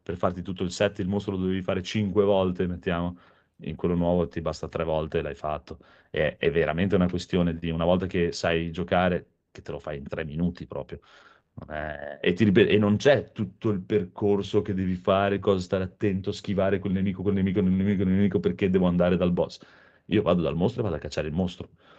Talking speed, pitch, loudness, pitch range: 225 wpm, 95 Hz, -26 LUFS, 85-100 Hz